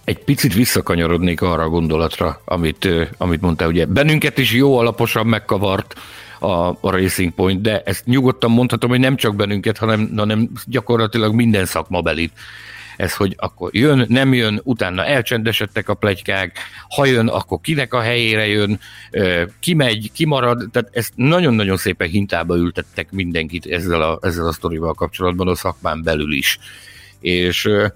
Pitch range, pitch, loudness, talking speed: 90-120 Hz, 105 Hz, -17 LUFS, 150 wpm